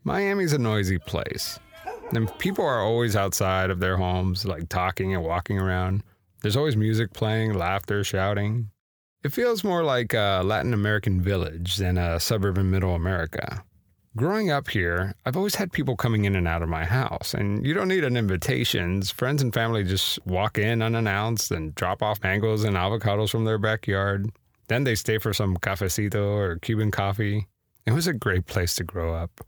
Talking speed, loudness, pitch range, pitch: 180 wpm, -25 LUFS, 95-115 Hz, 105 Hz